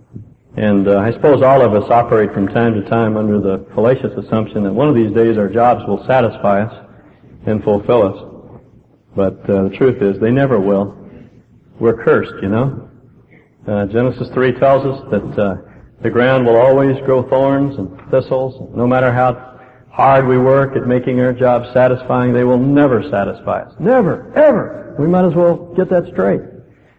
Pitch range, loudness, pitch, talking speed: 110-135 Hz, -14 LUFS, 125 Hz, 180 wpm